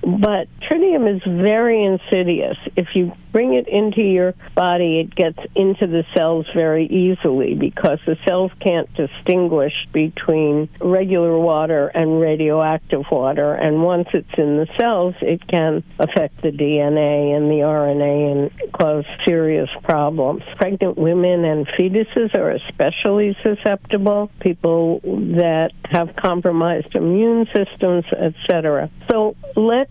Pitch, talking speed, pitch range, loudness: 175 Hz, 130 wpm, 155-195 Hz, -17 LUFS